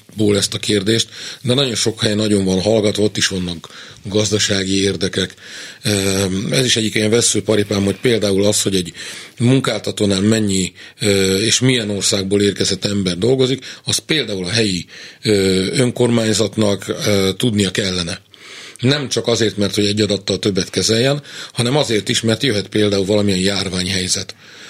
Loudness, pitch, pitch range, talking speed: -16 LUFS, 105 Hz, 95-115 Hz, 145 wpm